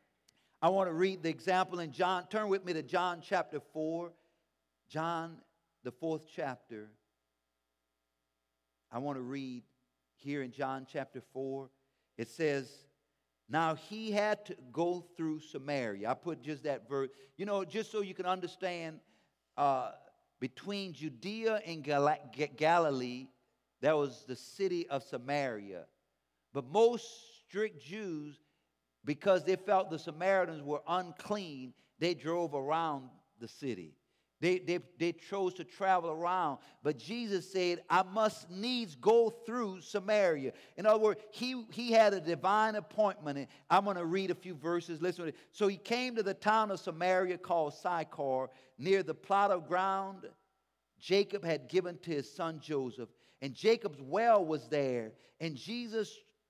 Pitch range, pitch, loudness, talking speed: 140-195 Hz, 165 Hz, -35 LUFS, 150 wpm